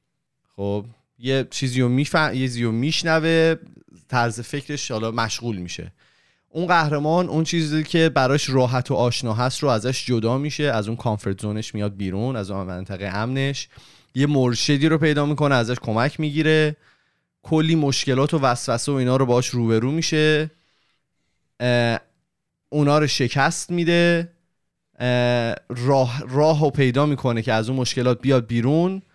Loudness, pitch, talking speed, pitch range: -21 LUFS, 135 Hz, 145 wpm, 120-155 Hz